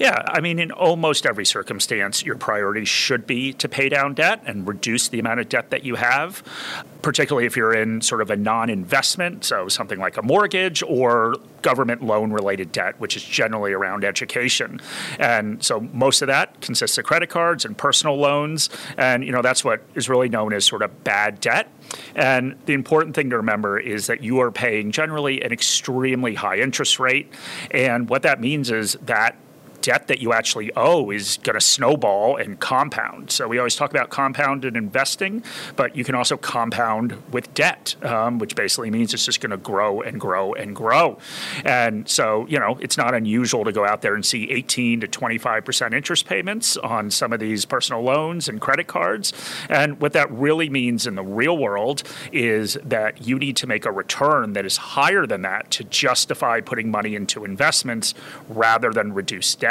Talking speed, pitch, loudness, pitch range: 195 wpm, 125 Hz, -20 LUFS, 110-145 Hz